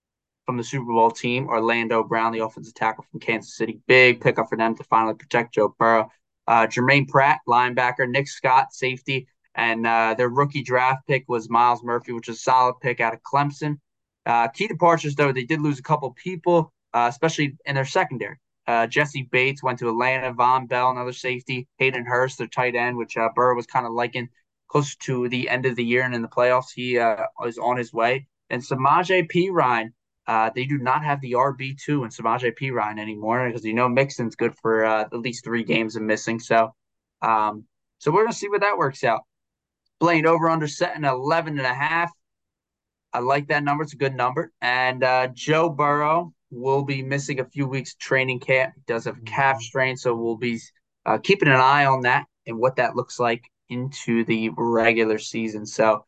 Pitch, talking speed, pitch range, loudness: 125 Hz, 200 wpm, 115-140 Hz, -22 LUFS